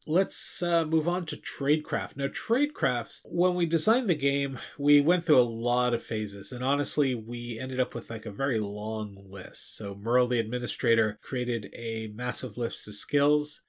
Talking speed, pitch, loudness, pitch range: 180 wpm, 125 Hz, -28 LUFS, 115-150 Hz